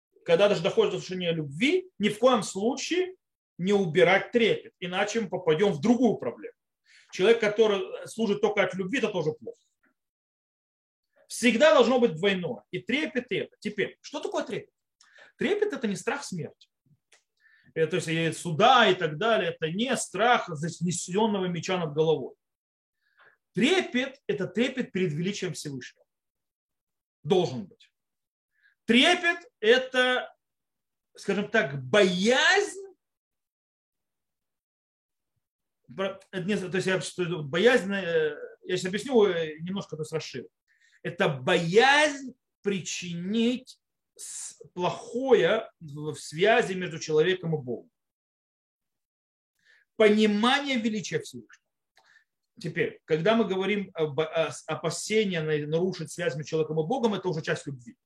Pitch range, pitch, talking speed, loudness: 170-250 Hz, 200 Hz, 115 wpm, -26 LUFS